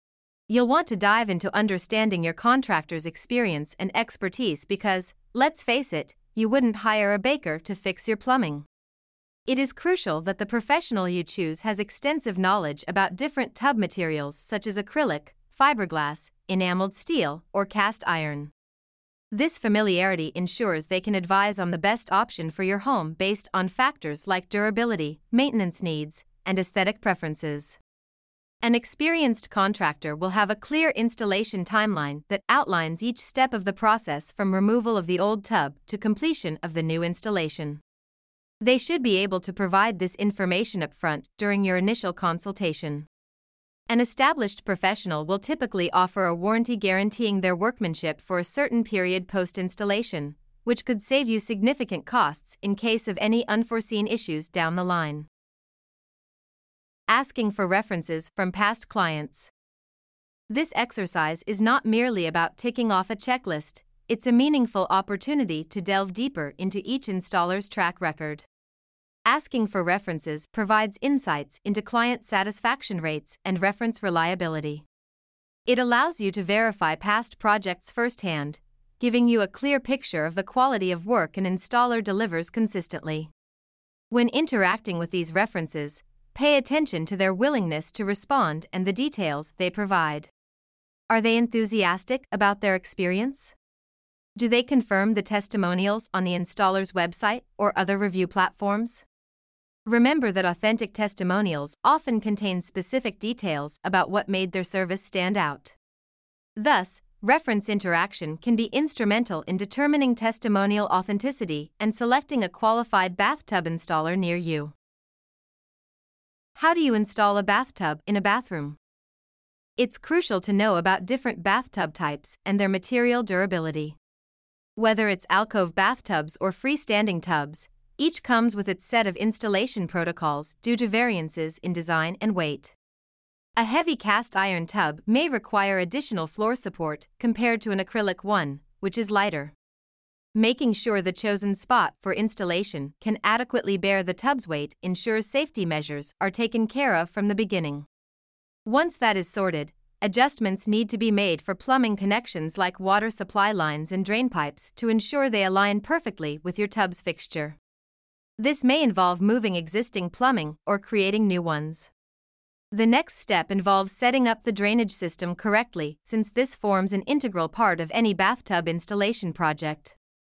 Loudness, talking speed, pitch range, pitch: -25 LUFS, 145 wpm, 175-230 Hz, 200 Hz